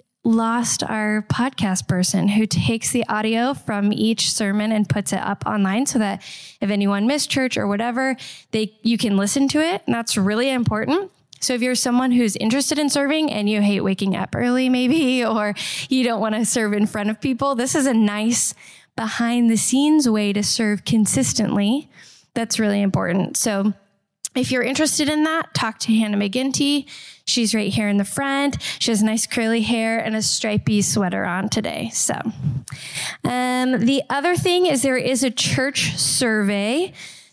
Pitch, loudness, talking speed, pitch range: 225 Hz, -20 LUFS, 180 wpm, 205-255 Hz